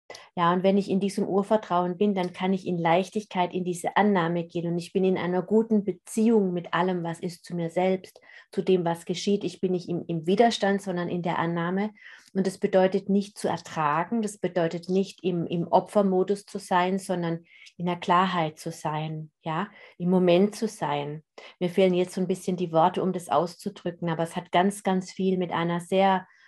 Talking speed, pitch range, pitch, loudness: 205 wpm, 170-195 Hz, 185 Hz, -26 LUFS